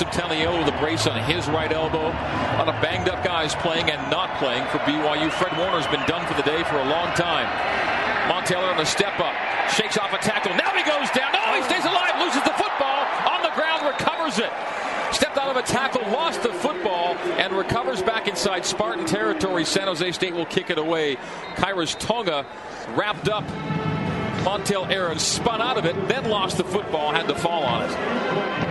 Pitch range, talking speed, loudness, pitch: 165-215 Hz, 200 wpm, -22 LUFS, 185 Hz